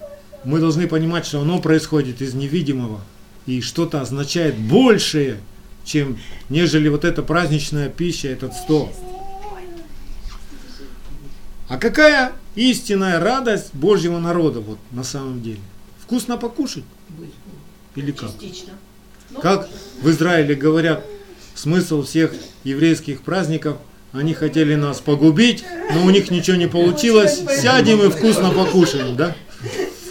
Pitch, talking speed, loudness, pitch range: 160 Hz, 115 wpm, -18 LUFS, 140-195 Hz